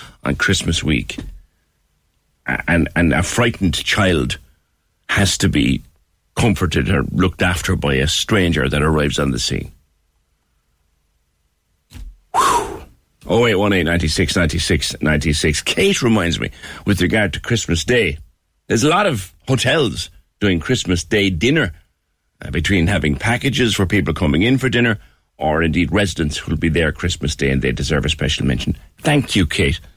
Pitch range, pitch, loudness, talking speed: 75-95 Hz, 85 Hz, -17 LUFS, 140 wpm